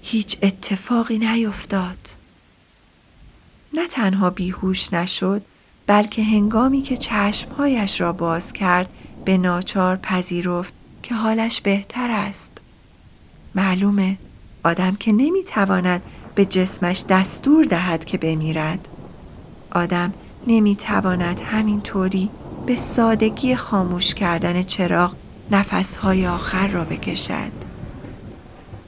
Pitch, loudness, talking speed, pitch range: 195 Hz, -20 LUFS, 90 wpm, 180-220 Hz